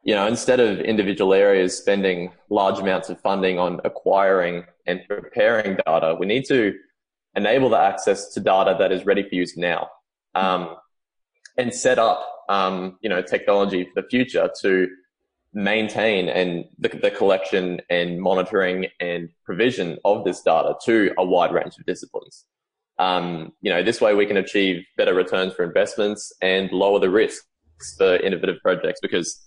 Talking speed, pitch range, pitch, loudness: 165 wpm, 90-105 Hz, 95 Hz, -21 LUFS